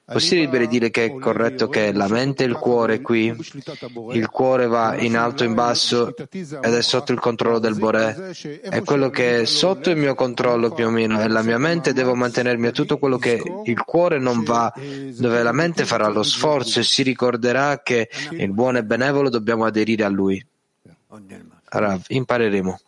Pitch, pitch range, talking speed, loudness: 120 Hz, 115-135 Hz, 195 wpm, -19 LUFS